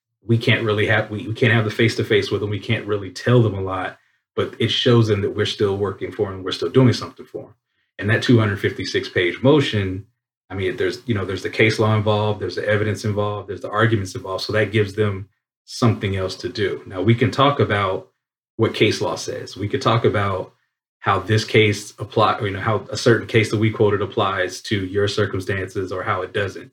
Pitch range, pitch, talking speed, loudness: 100-115 Hz, 105 Hz, 225 wpm, -20 LUFS